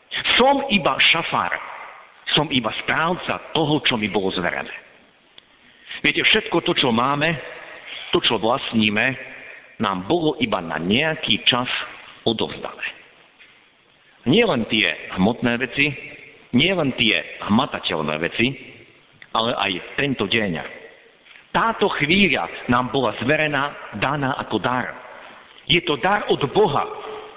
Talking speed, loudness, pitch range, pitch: 115 wpm, -20 LUFS, 120-190 Hz, 145 Hz